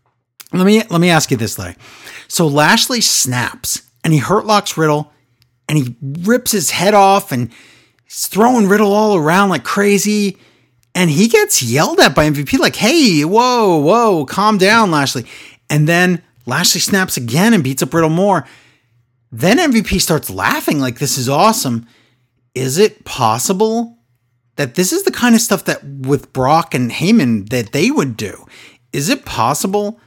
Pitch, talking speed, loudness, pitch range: 160 Hz, 170 wpm, -13 LUFS, 125-205 Hz